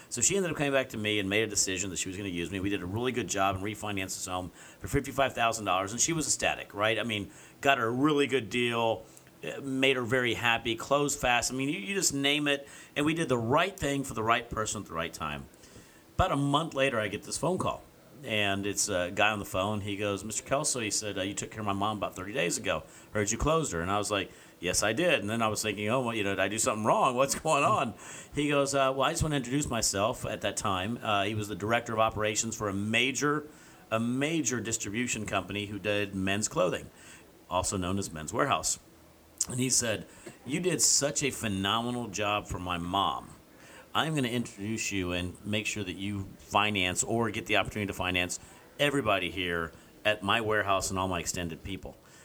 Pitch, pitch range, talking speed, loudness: 110 Hz, 100-130 Hz, 240 wpm, -29 LUFS